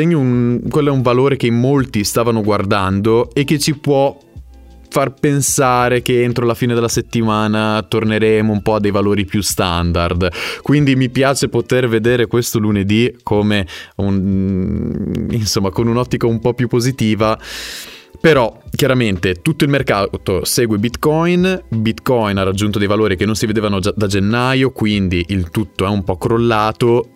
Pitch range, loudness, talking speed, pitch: 105-125 Hz, -15 LUFS, 155 wpm, 115 Hz